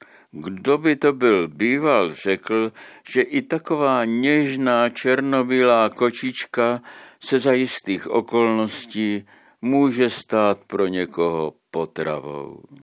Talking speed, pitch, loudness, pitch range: 100 wpm, 120 Hz, -21 LUFS, 105-135 Hz